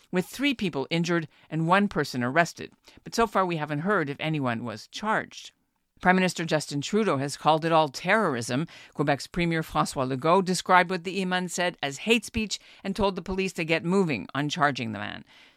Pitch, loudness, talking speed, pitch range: 165 Hz, -26 LUFS, 195 wpm, 145-190 Hz